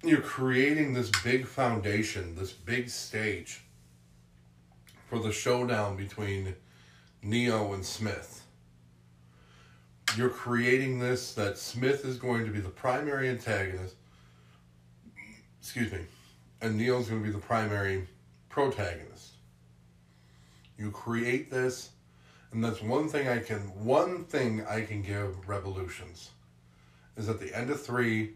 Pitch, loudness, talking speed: 100 Hz, -31 LUFS, 125 wpm